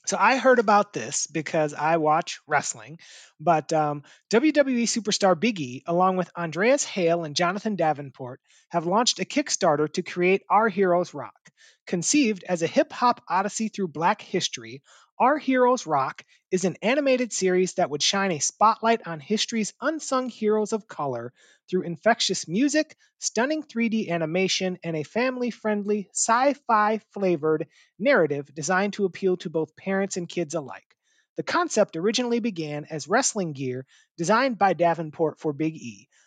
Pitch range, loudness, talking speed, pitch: 160-230 Hz, -24 LUFS, 155 wpm, 190 Hz